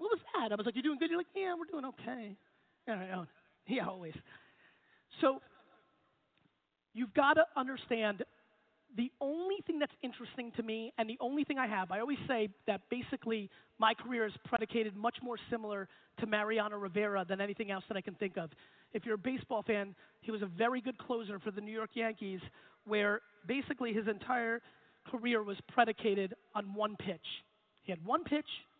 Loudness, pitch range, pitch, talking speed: -37 LUFS, 210-255 Hz, 225 Hz, 185 wpm